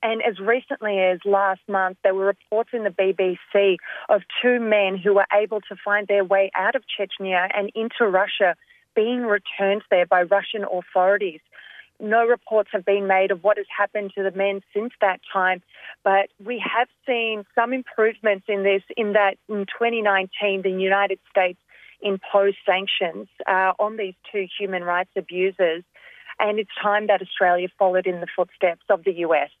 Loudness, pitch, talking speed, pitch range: -22 LUFS, 200 Hz, 170 wpm, 190-215 Hz